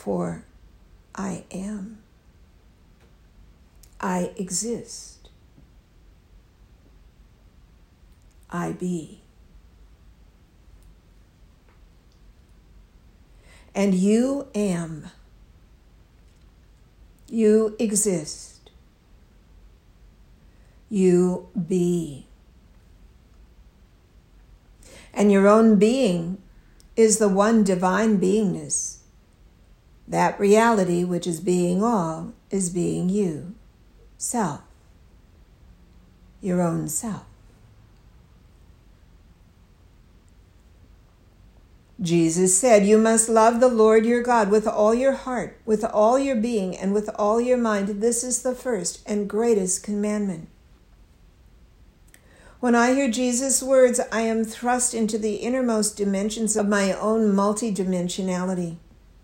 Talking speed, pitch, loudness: 80 wpm, 180 Hz, -22 LUFS